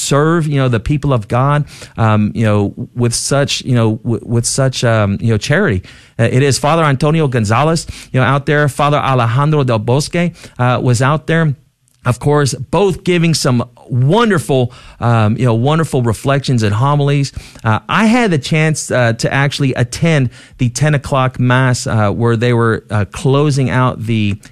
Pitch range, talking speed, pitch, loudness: 115-145 Hz, 175 wpm, 130 Hz, -14 LUFS